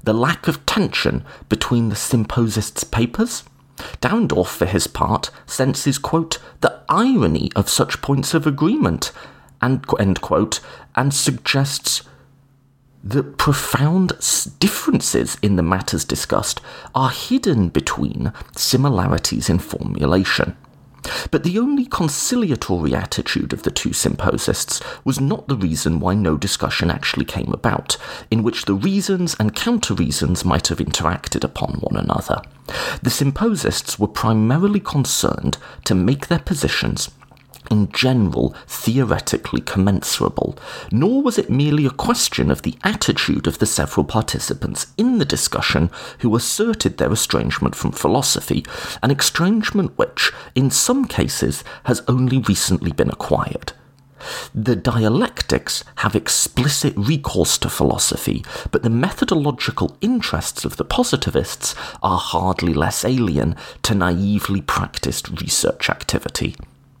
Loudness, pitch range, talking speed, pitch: -19 LUFS, 100-160 Hz, 125 wpm, 130 Hz